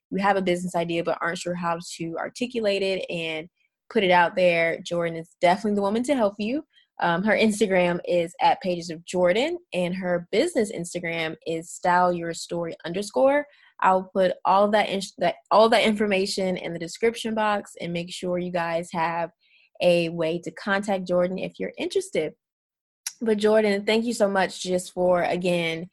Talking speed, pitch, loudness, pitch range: 180 wpm, 180 Hz, -24 LUFS, 170-205 Hz